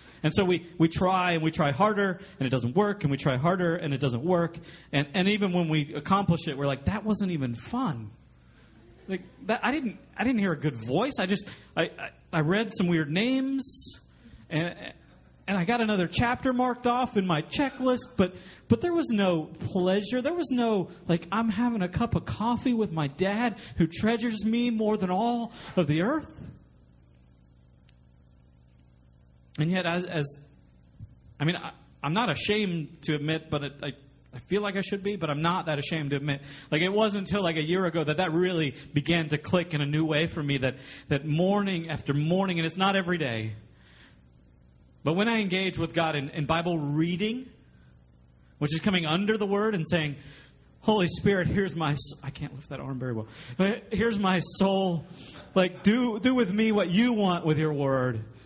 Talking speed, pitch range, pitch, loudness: 200 wpm, 145-200 Hz, 170 Hz, -27 LUFS